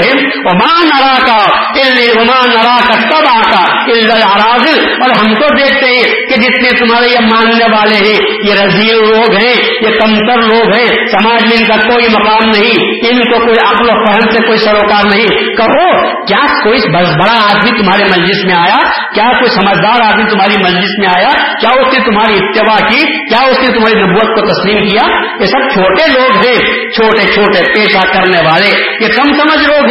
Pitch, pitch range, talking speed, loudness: 225 Hz, 210-250 Hz, 170 wpm, -6 LUFS